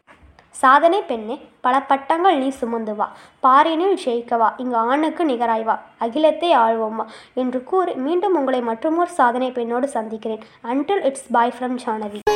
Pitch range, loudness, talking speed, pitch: 230-300 Hz, -19 LUFS, 130 wpm, 255 Hz